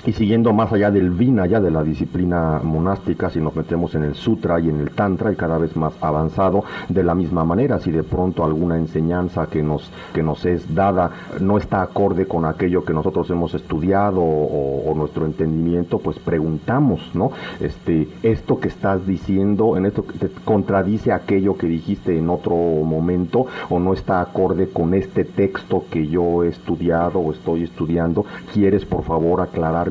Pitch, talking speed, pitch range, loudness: 85 Hz, 180 wpm, 80-95 Hz, -20 LUFS